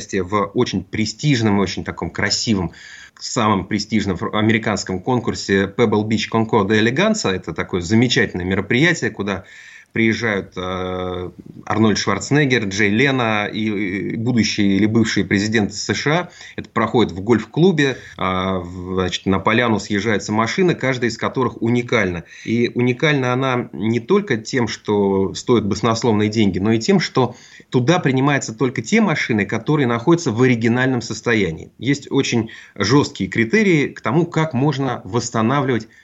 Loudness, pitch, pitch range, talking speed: -18 LUFS, 110 Hz, 100-125 Hz, 130 wpm